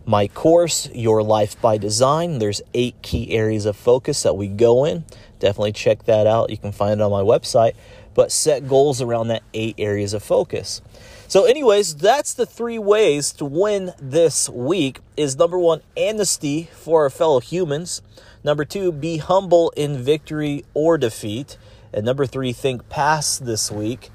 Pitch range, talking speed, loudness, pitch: 110-160 Hz, 170 wpm, -19 LUFS, 130 Hz